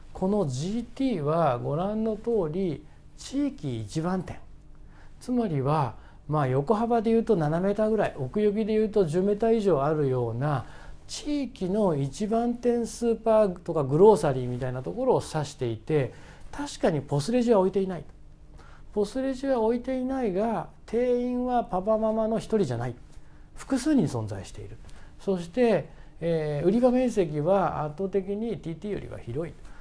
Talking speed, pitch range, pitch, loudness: 305 characters per minute, 150-230 Hz, 195 Hz, -27 LUFS